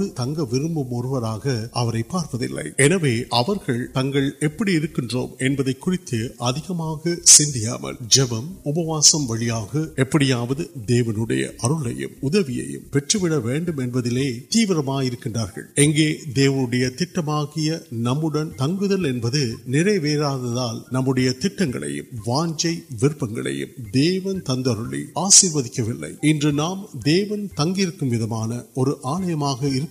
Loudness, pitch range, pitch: -21 LUFS, 120-160 Hz, 135 Hz